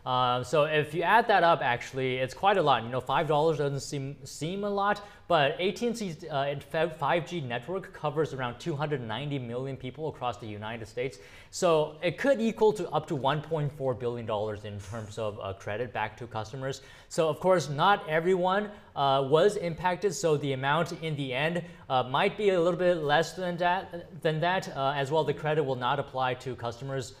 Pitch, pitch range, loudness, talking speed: 150 Hz, 130-175 Hz, -29 LUFS, 195 wpm